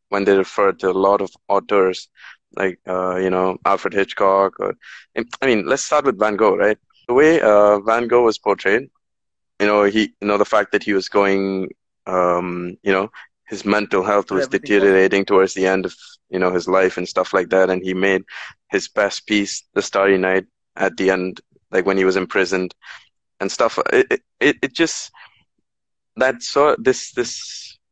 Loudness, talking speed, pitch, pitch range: -18 LUFS, 195 wpm, 95 Hz, 95-105 Hz